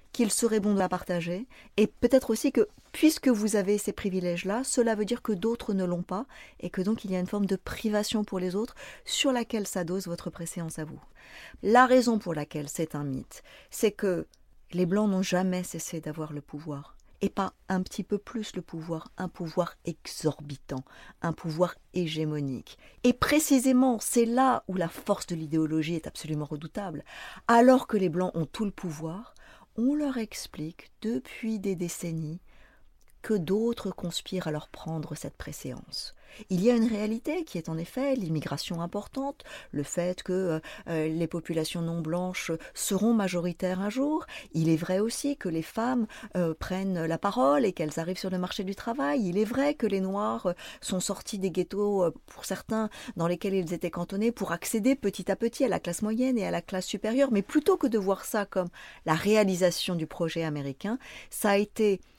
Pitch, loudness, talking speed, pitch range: 190 Hz, -29 LUFS, 190 wpm, 170-225 Hz